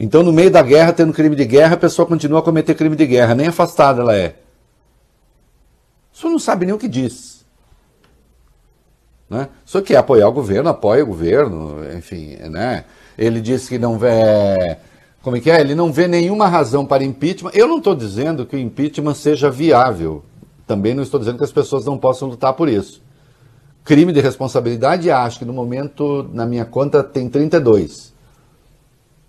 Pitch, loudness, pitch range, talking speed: 140 Hz, -15 LUFS, 120-160 Hz, 185 wpm